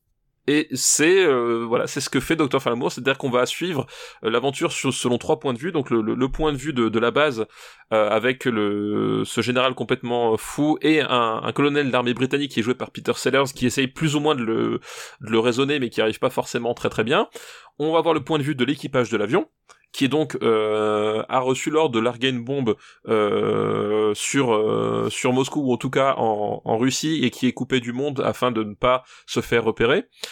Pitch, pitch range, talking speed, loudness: 130 Hz, 115-145 Hz, 230 wpm, -22 LUFS